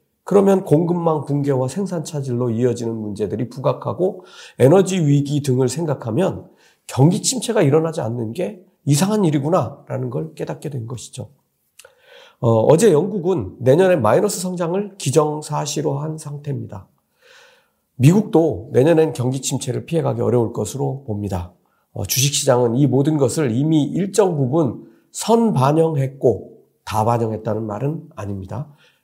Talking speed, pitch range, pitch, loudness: 310 characters per minute, 125-170 Hz, 145 Hz, -19 LUFS